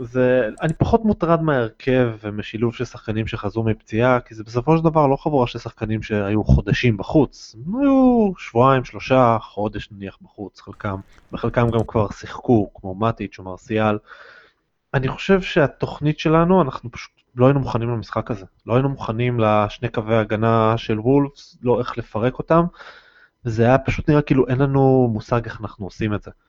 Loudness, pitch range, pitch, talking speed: -20 LUFS, 110-140 Hz, 120 Hz, 165 wpm